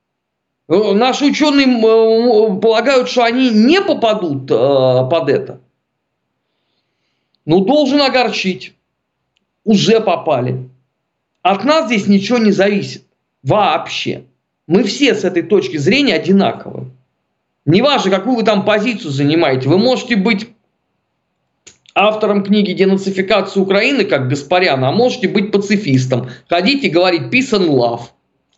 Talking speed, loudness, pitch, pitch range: 110 wpm, -13 LUFS, 200 Hz, 170-230 Hz